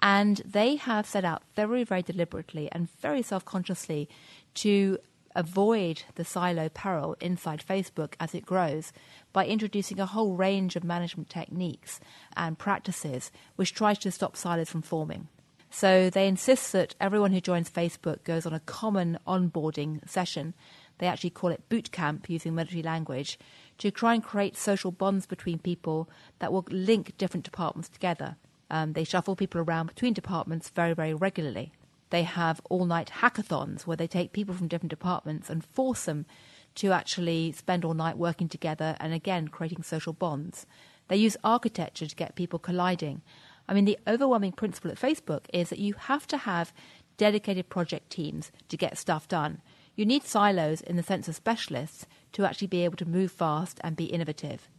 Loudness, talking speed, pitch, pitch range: -30 LUFS, 170 wpm, 175 Hz, 165-195 Hz